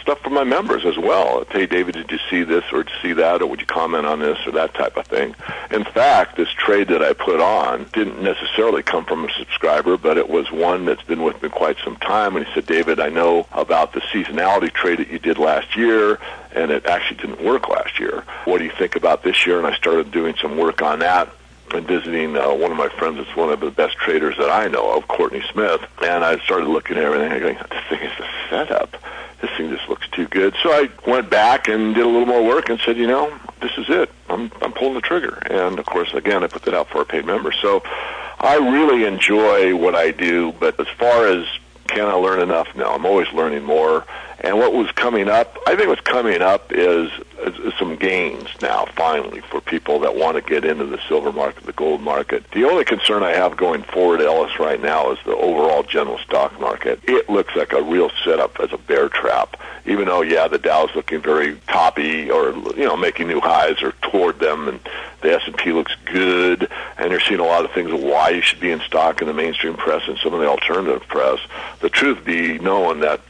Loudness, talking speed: -18 LUFS, 235 wpm